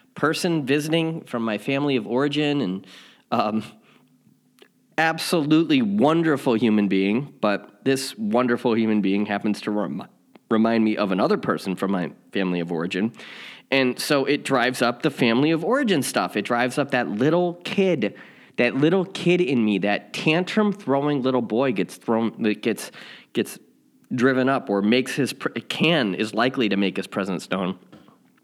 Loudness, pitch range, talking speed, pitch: -22 LUFS, 105-155 Hz, 160 wpm, 130 Hz